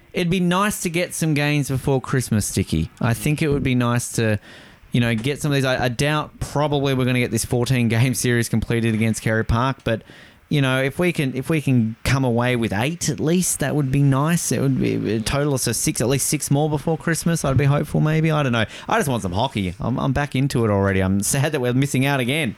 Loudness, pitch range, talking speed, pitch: -20 LUFS, 115-150 Hz, 250 wpm, 130 Hz